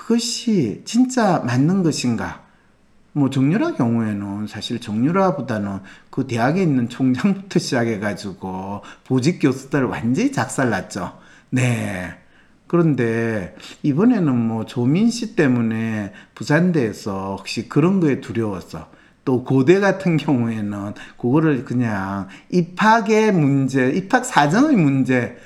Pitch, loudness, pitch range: 130 Hz, -19 LUFS, 110-170 Hz